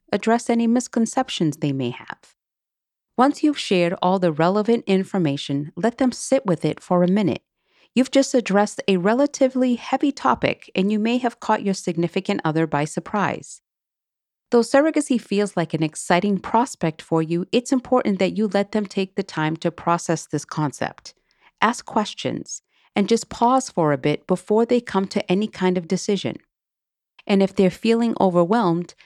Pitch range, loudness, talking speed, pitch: 175-235 Hz, -21 LUFS, 165 wpm, 200 Hz